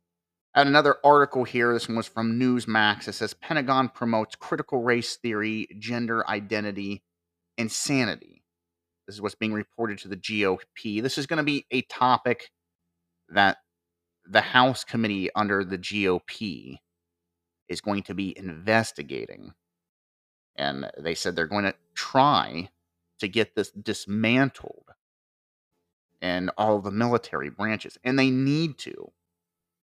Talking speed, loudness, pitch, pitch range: 135 wpm, -25 LUFS, 105 Hz, 85-115 Hz